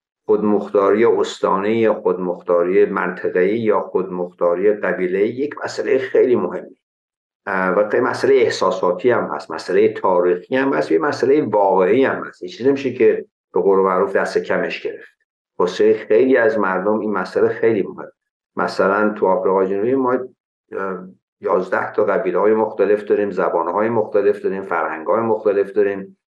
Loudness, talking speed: -18 LUFS, 140 wpm